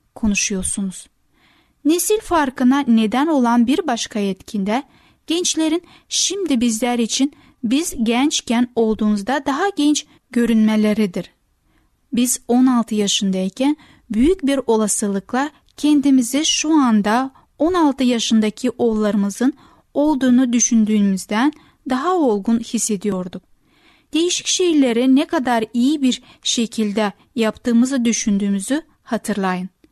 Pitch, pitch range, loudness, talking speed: 245 Hz, 215-290 Hz, -18 LUFS, 90 wpm